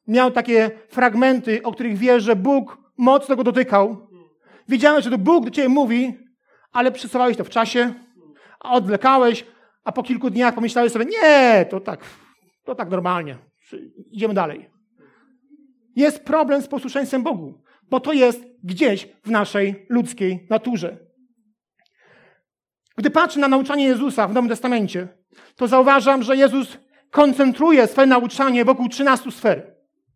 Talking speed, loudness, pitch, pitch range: 140 wpm, -18 LUFS, 245 Hz, 220-270 Hz